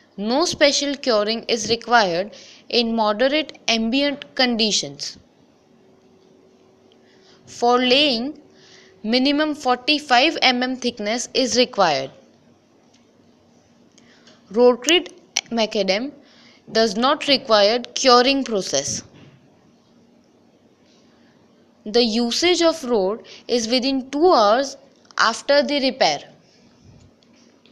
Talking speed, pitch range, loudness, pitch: 75 wpm, 225-275 Hz, -19 LUFS, 245 Hz